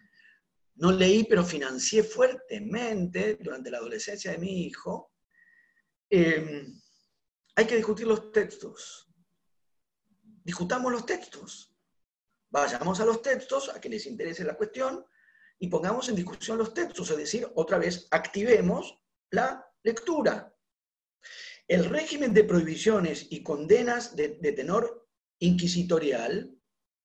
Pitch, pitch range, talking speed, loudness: 215 Hz, 175-250 Hz, 120 wpm, -28 LUFS